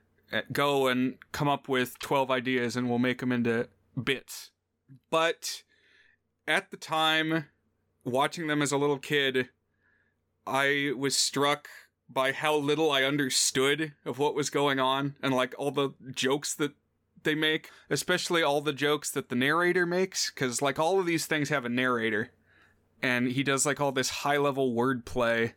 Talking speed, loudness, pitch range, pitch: 165 wpm, -28 LUFS, 130-150 Hz, 140 Hz